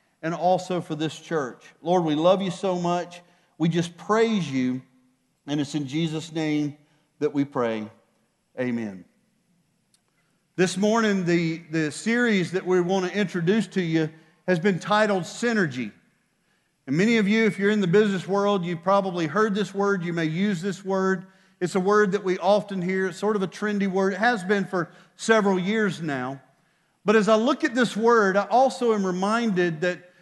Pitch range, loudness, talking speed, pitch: 165-205 Hz, -24 LUFS, 185 wpm, 185 Hz